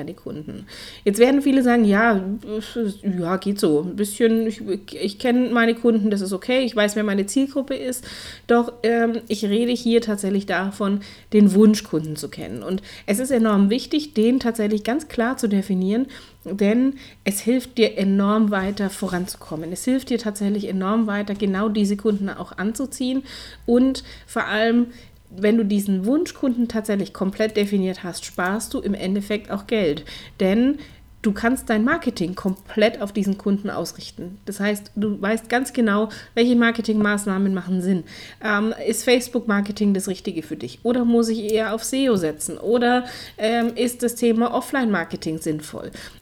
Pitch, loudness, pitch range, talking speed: 215 Hz, -21 LUFS, 195-235 Hz, 160 wpm